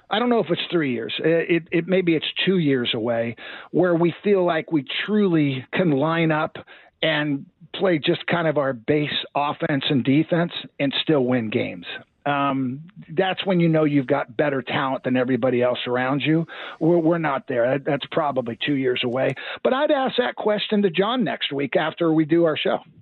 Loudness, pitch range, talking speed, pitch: -22 LUFS, 135-175 Hz, 195 wpm, 155 Hz